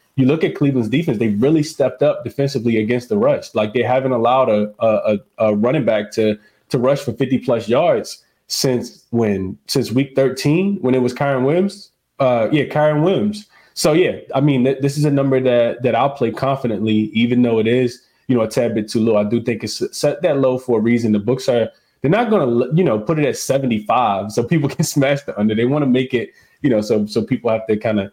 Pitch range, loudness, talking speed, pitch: 115-140 Hz, -17 LUFS, 235 wpm, 125 Hz